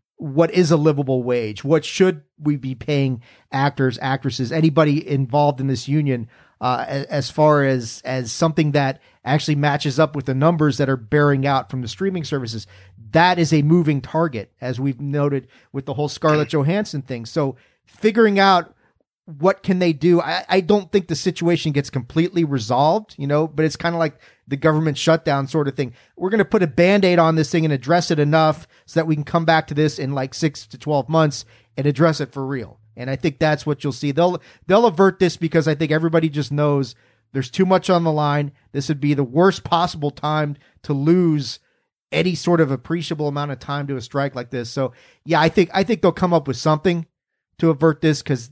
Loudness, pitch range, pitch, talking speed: -19 LUFS, 135-165 Hz, 150 Hz, 215 wpm